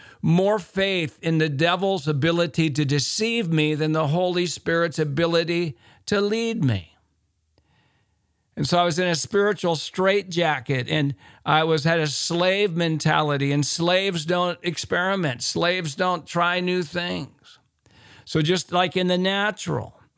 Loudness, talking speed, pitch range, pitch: -22 LUFS, 140 wpm, 145-180 Hz, 170 Hz